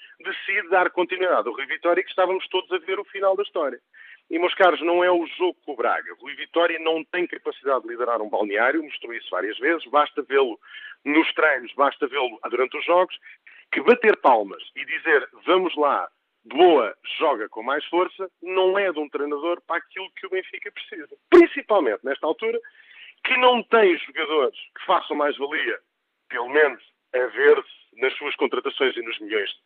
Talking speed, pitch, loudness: 185 wpm, 195 Hz, -22 LUFS